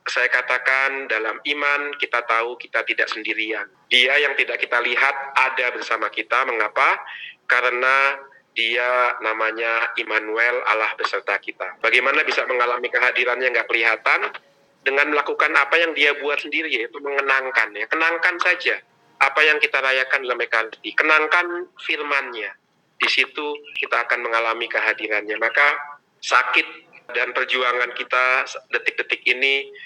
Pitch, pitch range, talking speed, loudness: 130 Hz, 120-145 Hz, 130 wpm, -19 LUFS